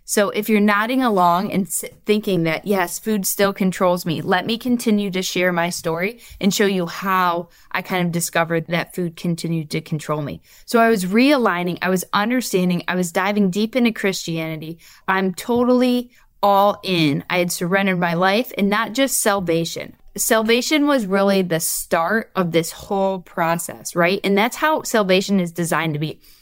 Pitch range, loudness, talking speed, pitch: 175-210 Hz, -19 LUFS, 175 wpm, 190 Hz